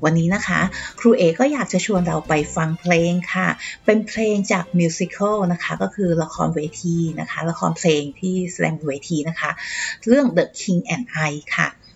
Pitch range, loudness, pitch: 160-200 Hz, -20 LUFS, 175 Hz